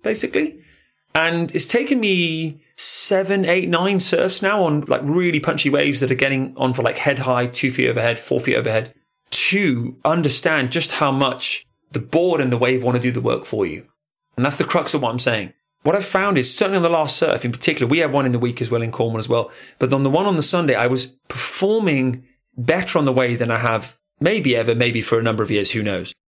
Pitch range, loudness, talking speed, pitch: 125-170 Hz, -19 LUFS, 235 wpm, 140 Hz